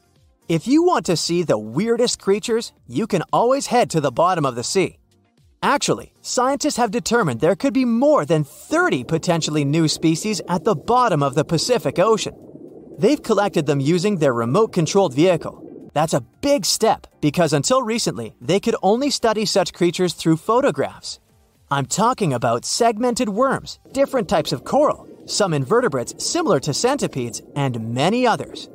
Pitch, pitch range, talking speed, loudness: 190 Hz, 155-240 Hz, 165 wpm, -19 LUFS